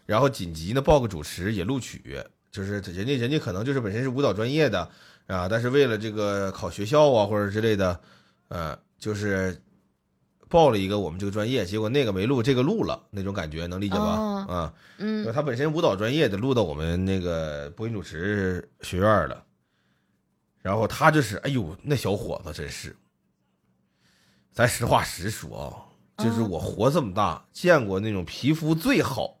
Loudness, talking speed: -25 LUFS, 275 characters per minute